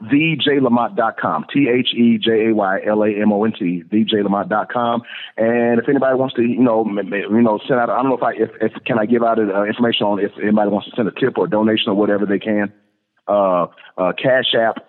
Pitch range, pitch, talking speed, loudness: 105-120 Hz, 110 Hz, 230 wpm, -17 LUFS